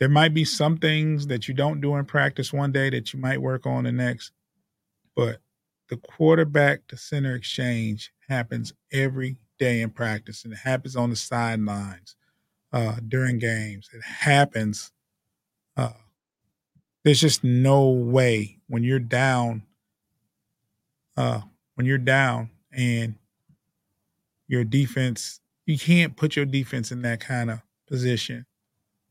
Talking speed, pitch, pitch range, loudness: 135 wpm, 125 Hz, 115-135 Hz, -24 LUFS